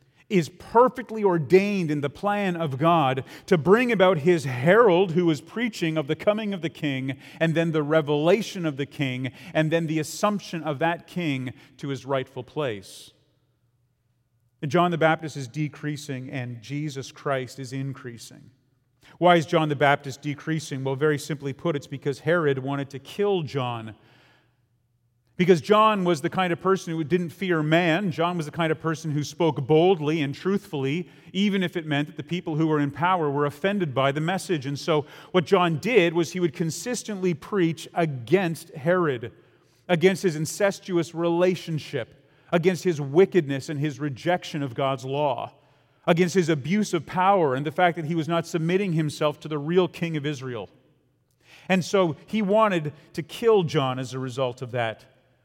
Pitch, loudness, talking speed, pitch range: 155 Hz, -24 LUFS, 175 wpm, 140-180 Hz